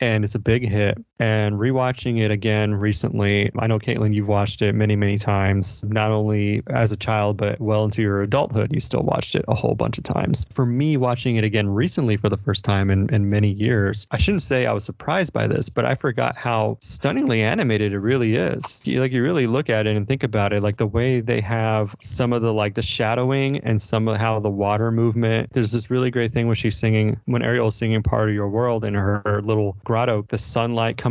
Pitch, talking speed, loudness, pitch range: 110 Hz, 235 wpm, -21 LUFS, 105-120 Hz